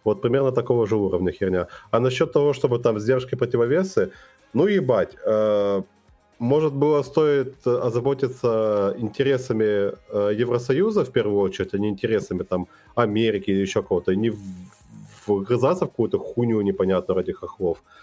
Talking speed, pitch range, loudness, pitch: 145 wpm, 100-130 Hz, -22 LUFS, 115 Hz